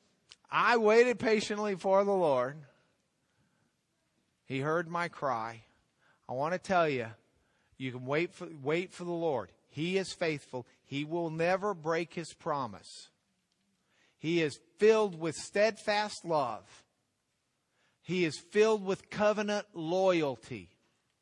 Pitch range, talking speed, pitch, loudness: 145-200 Hz, 125 wpm, 170 Hz, -31 LUFS